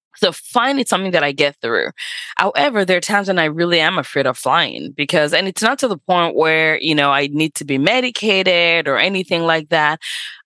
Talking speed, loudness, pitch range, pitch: 220 wpm, -16 LUFS, 155-190 Hz, 170 Hz